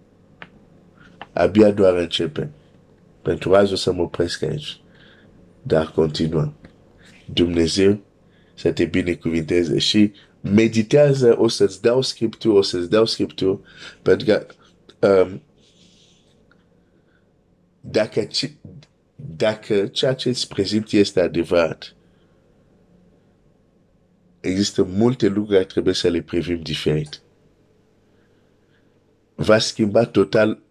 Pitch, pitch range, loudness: 100 Hz, 85-110 Hz, -19 LUFS